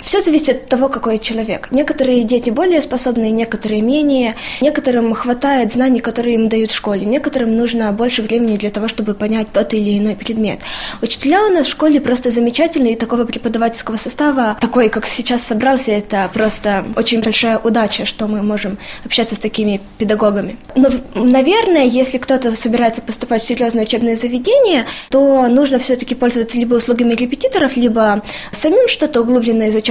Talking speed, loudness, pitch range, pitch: 165 wpm, -14 LUFS, 220-260 Hz, 235 Hz